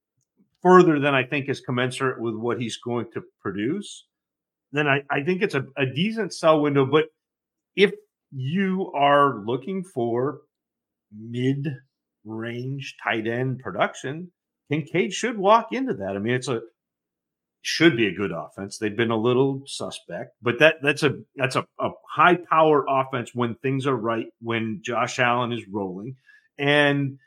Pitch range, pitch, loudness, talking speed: 120-155 Hz, 135 Hz, -23 LUFS, 155 wpm